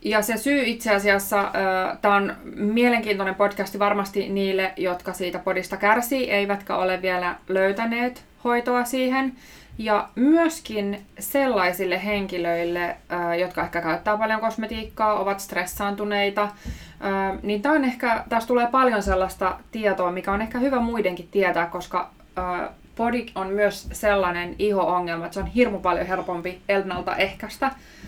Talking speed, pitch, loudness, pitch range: 135 wpm, 200 Hz, -23 LUFS, 185-225 Hz